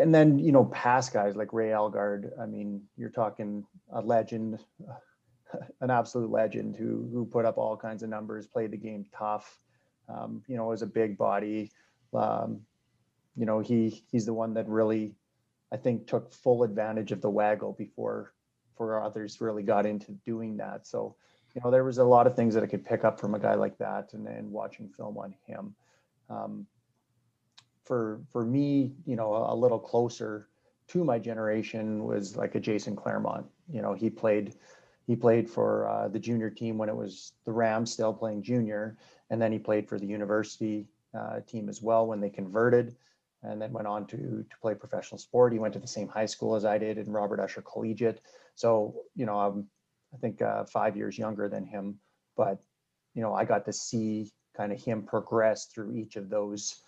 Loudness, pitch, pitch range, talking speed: -30 LUFS, 110 Hz, 105-115 Hz, 200 wpm